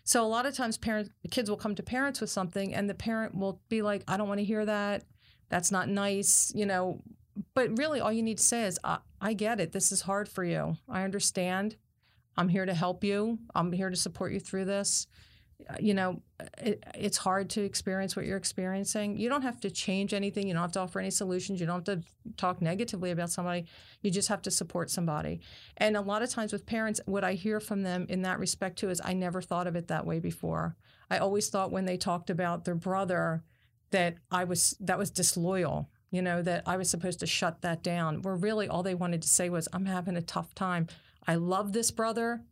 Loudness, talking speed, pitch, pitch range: -31 LUFS, 235 wpm, 190 Hz, 175-205 Hz